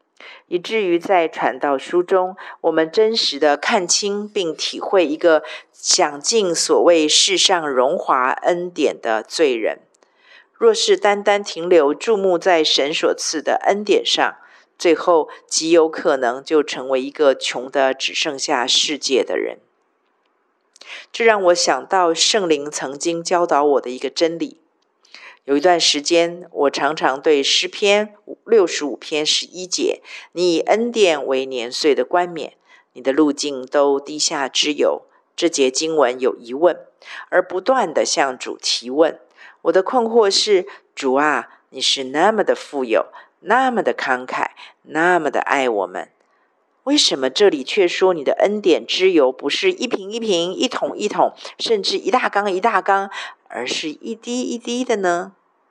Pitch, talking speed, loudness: 195 Hz, 220 characters per minute, -18 LUFS